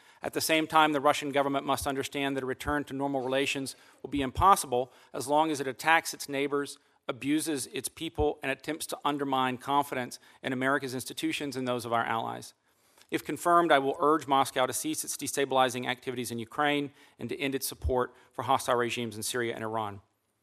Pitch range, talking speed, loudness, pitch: 130-145 Hz, 195 wpm, -29 LUFS, 140 Hz